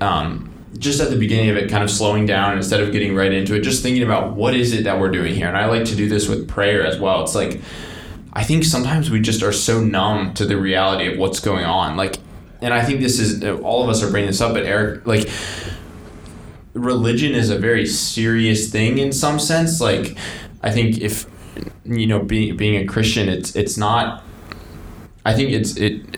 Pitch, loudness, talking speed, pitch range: 105 Hz, -18 LUFS, 220 wpm, 95-115 Hz